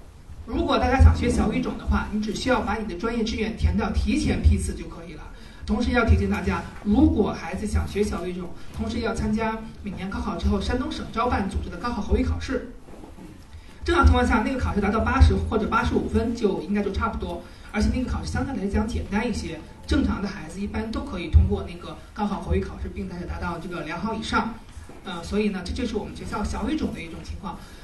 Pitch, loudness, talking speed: 185 Hz, -25 LUFS, 350 characters per minute